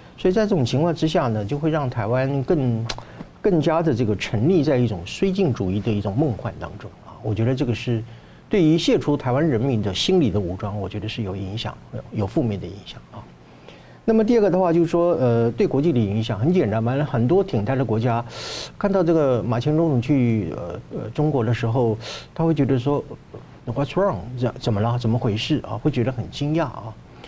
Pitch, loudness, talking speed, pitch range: 125 Hz, -22 LUFS, 320 characters per minute, 110-160 Hz